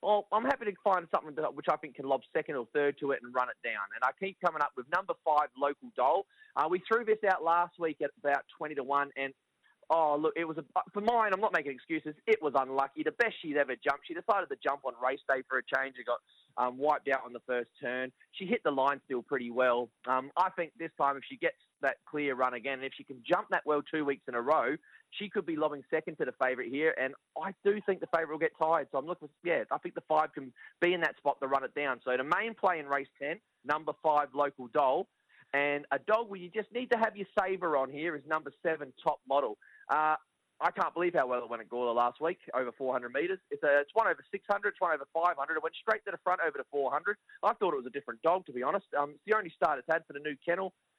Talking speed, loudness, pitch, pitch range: 270 wpm, -32 LUFS, 155 Hz, 135-190 Hz